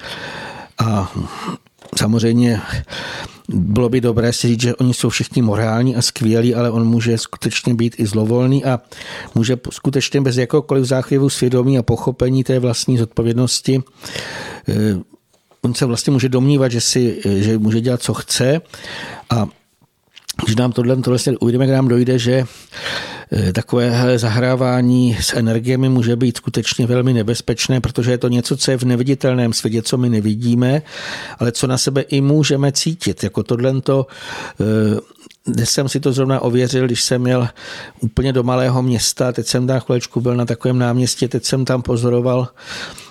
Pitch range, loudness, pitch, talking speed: 115-130 Hz, -17 LUFS, 125 Hz, 155 wpm